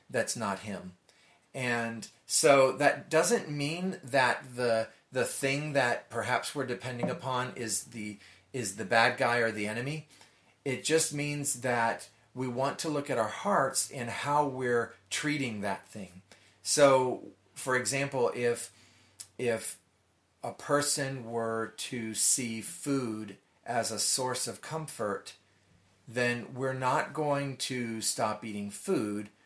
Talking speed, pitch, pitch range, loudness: 135 wpm, 120 Hz, 110-135 Hz, -30 LUFS